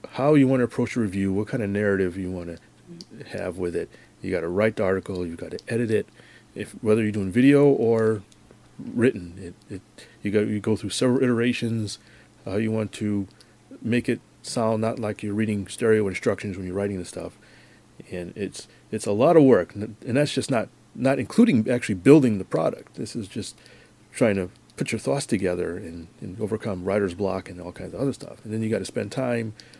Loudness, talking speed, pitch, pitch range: -24 LUFS, 205 wpm, 105 Hz, 95-120 Hz